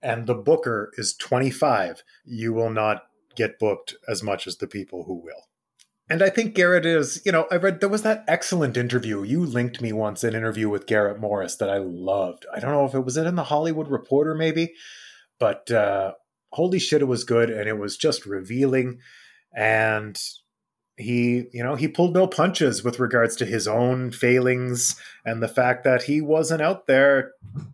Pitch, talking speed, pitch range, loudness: 125 Hz, 195 wpm, 115-155 Hz, -23 LUFS